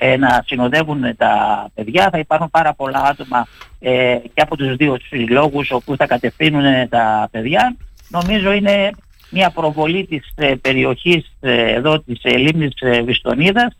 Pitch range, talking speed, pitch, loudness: 125-160 Hz, 150 wpm, 140 Hz, -15 LUFS